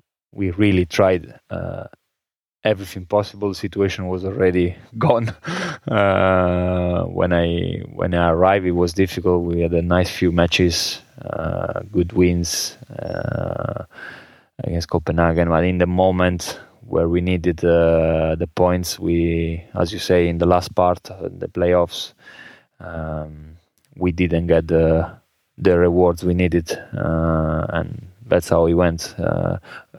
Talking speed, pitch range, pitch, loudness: 140 wpm, 85-95 Hz, 90 Hz, -19 LUFS